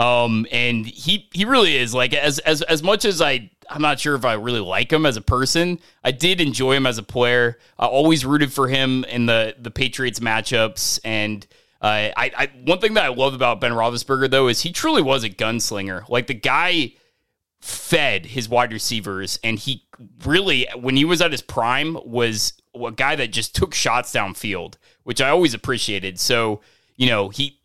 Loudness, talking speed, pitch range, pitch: -19 LUFS, 200 wpm, 115-145 Hz, 125 Hz